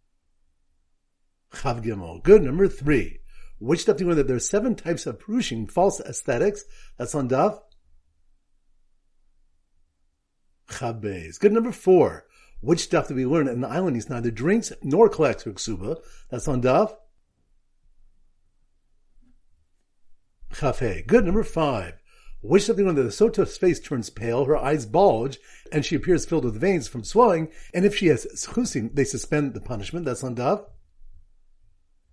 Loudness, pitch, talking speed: -23 LUFS, 130 Hz, 145 wpm